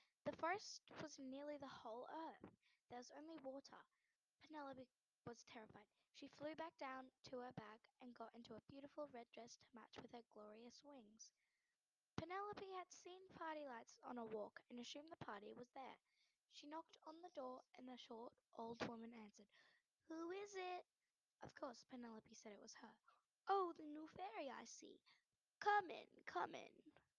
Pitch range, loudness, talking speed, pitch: 235-320 Hz, -54 LUFS, 175 wpm, 270 Hz